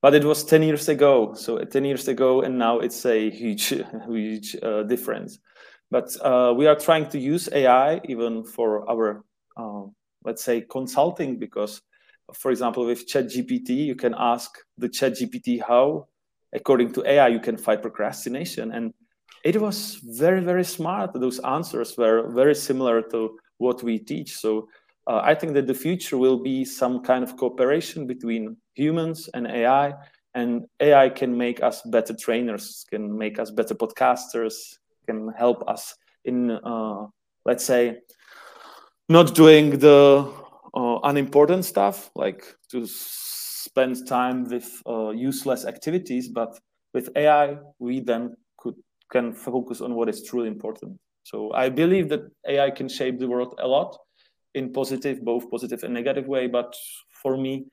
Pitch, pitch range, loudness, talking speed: 130 Hz, 115-145 Hz, -22 LUFS, 160 wpm